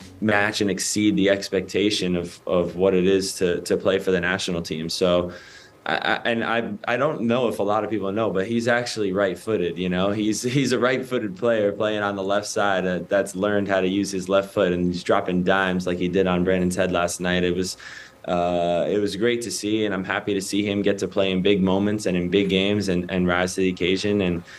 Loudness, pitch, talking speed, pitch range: -22 LUFS, 95 Hz, 235 wpm, 90-105 Hz